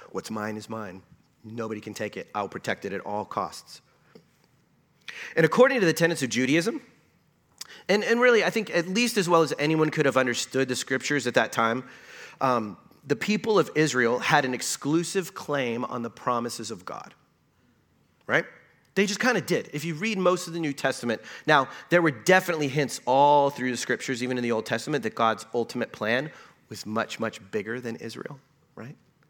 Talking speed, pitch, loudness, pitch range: 190 wpm, 140 Hz, -25 LUFS, 120-175 Hz